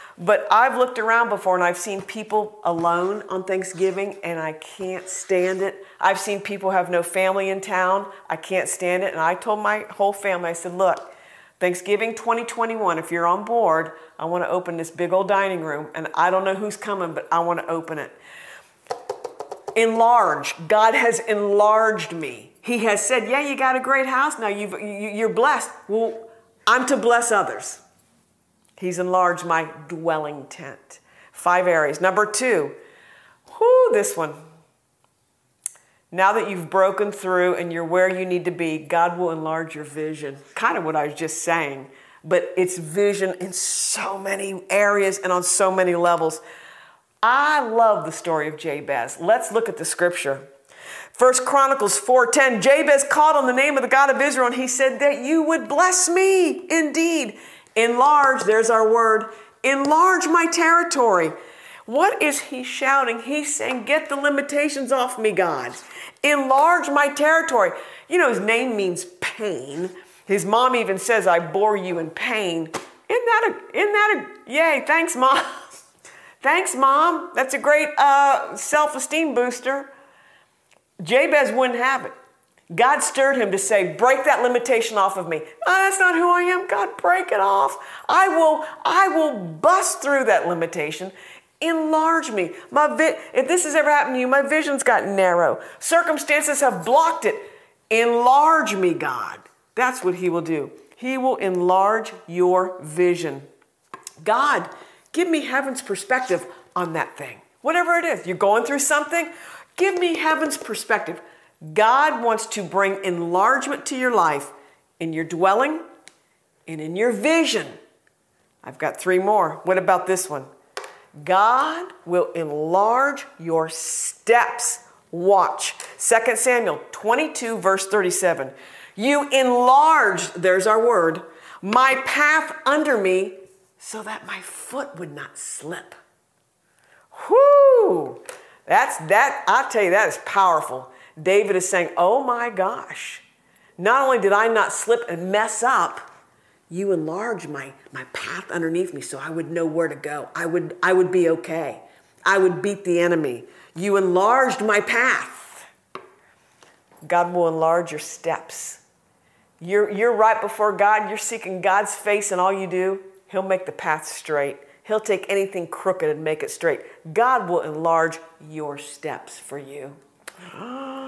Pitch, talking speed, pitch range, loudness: 210 Hz, 155 wpm, 180-270 Hz, -20 LUFS